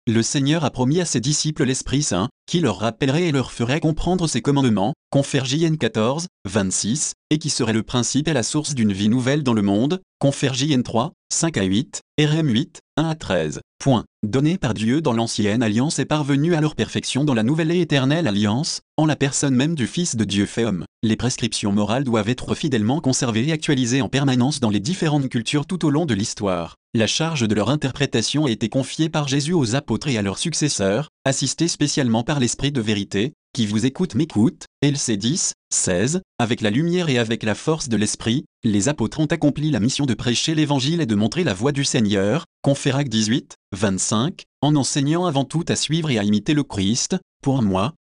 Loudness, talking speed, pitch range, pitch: -21 LUFS, 205 wpm, 110-150 Hz, 135 Hz